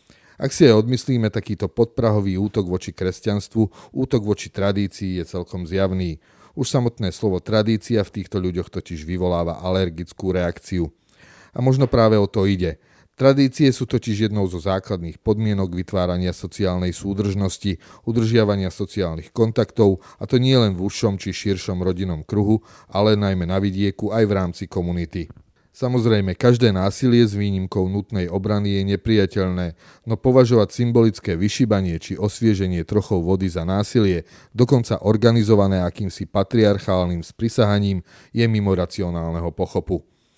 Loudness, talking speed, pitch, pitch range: -21 LUFS, 135 wpm, 100 Hz, 95-110 Hz